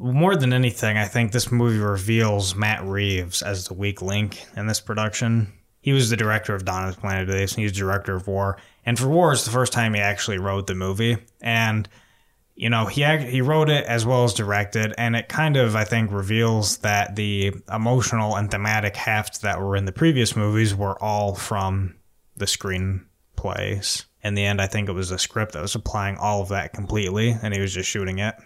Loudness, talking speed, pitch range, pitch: -22 LUFS, 215 wpm, 100-115 Hz, 105 Hz